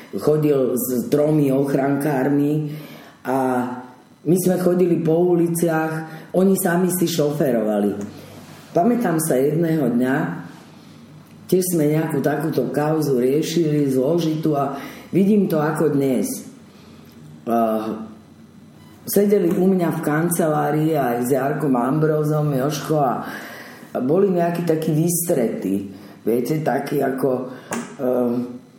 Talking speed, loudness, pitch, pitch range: 105 wpm, -20 LUFS, 150 Hz, 130-170 Hz